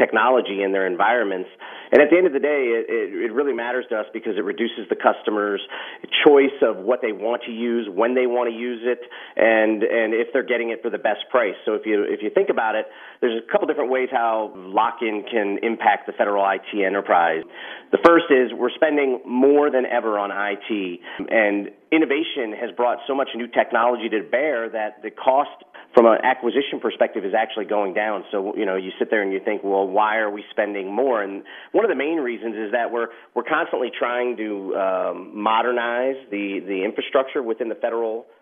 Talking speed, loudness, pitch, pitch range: 210 wpm, -21 LUFS, 115 Hz, 105-130 Hz